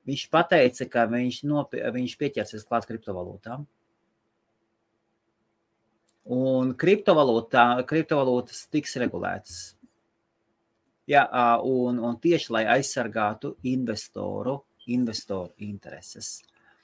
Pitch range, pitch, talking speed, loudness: 110-140 Hz, 125 Hz, 70 wpm, -25 LUFS